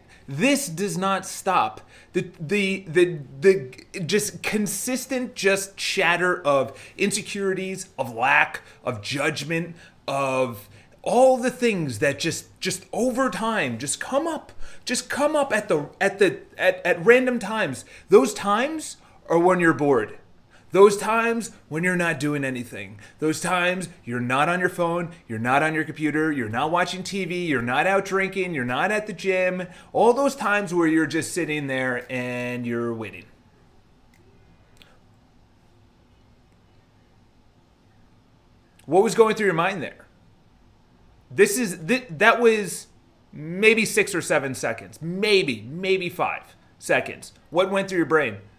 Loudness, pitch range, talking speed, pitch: -23 LUFS, 140-200 Hz, 145 wpm, 180 Hz